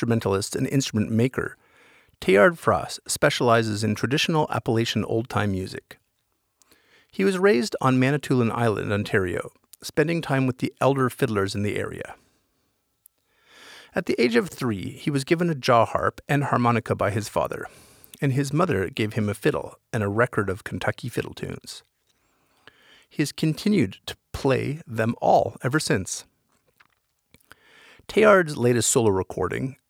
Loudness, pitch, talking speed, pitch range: -23 LUFS, 130 Hz, 145 wpm, 110-150 Hz